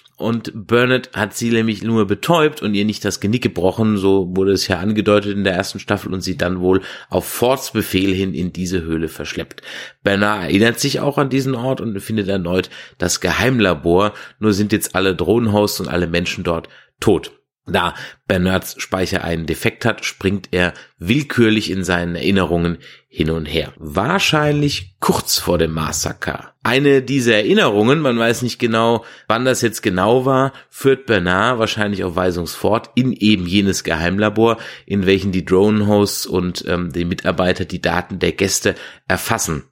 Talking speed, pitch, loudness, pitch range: 165 wpm, 100 Hz, -17 LUFS, 90-115 Hz